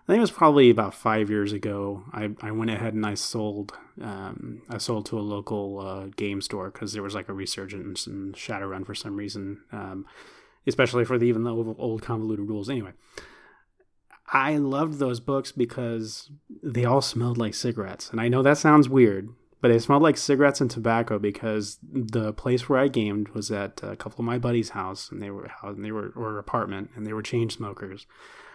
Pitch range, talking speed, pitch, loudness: 100-120 Hz, 205 wpm, 110 Hz, -25 LUFS